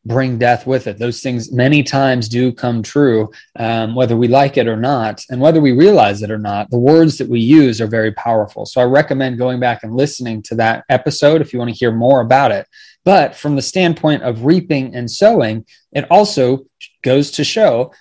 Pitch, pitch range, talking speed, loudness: 125 Hz, 115-140 Hz, 215 wpm, -14 LUFS